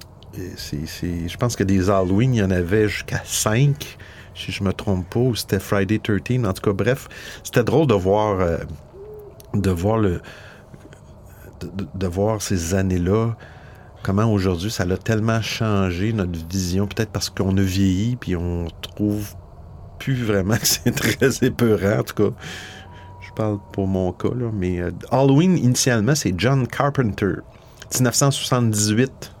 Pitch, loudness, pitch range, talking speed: 100 Hz, -21 LUFS, 95-115 Hz, 160 wpm